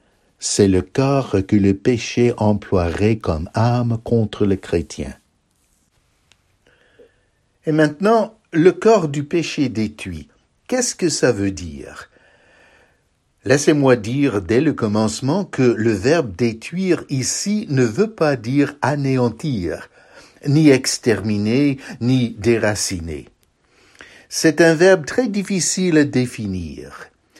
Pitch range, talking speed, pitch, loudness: 105-155 Hz, 110 wpm, 125 Hz, -18 LUFS